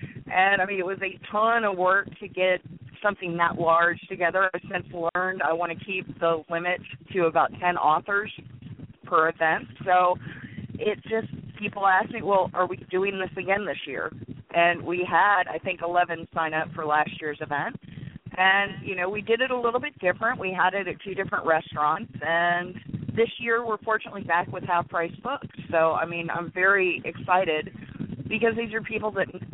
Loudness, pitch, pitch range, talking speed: -25 LUFS, 180 Hz, 165-195 Hz, 190 wpm